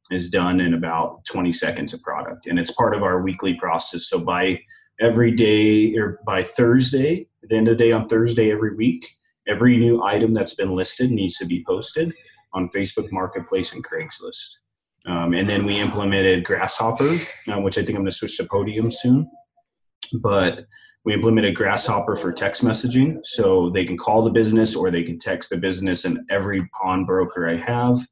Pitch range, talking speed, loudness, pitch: 95-125 Hz, 190 wpm, -20 LUFS, 110 Hz